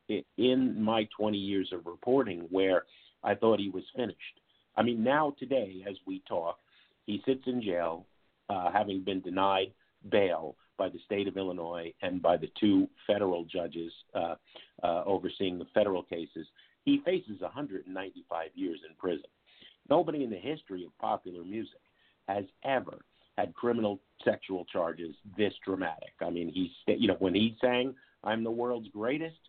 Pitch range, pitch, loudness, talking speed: 95-120 Hz, 100 Hz, -32 LUFS, 160 wpm